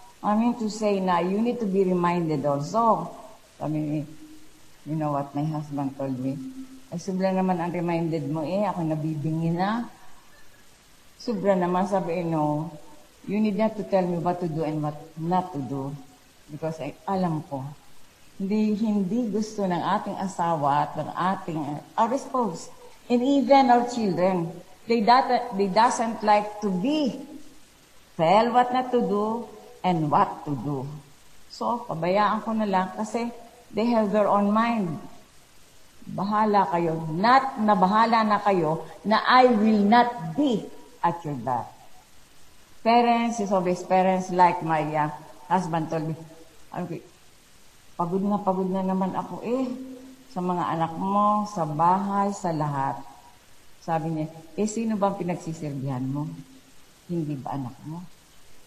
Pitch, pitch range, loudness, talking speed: 185 Hz, 160-220 Hz, -25 LUFS, 145 wpm